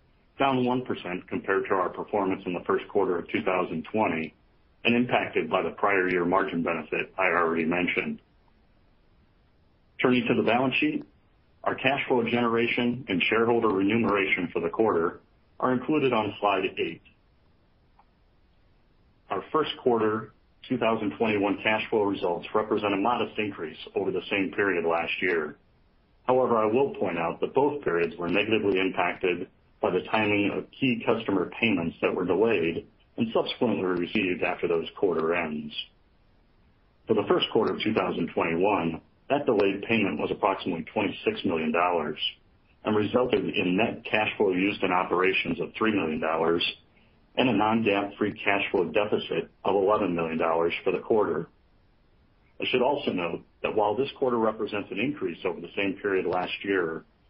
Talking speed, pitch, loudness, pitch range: 150 wpm, 100 Hz, -26 LUFS, 85-115 Hz